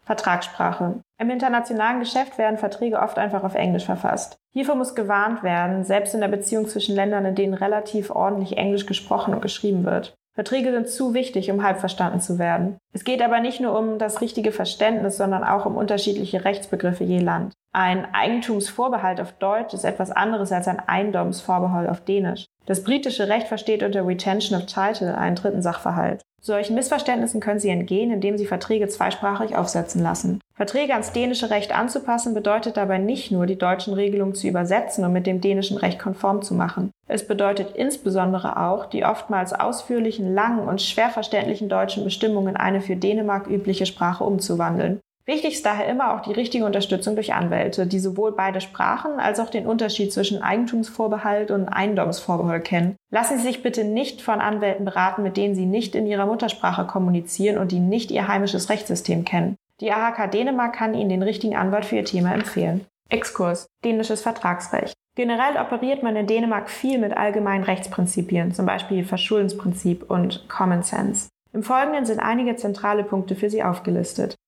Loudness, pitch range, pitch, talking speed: -23 LUFS, 190-220 Hz, 205 Hz, 175 wpm